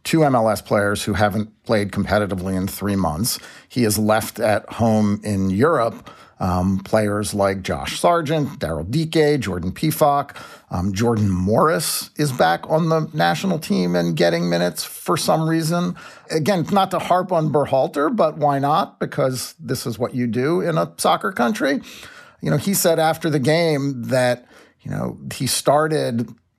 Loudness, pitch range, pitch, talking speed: -20 LUFS, 100-155 Hz, 120 Hz, 160 wpm